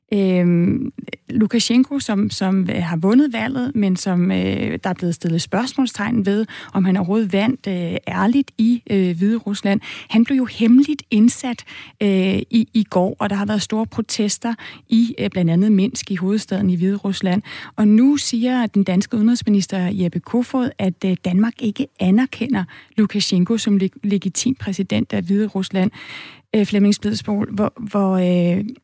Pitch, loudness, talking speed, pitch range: 205 Hz, -19 LUFS, 160 wpm, 190-230 Hz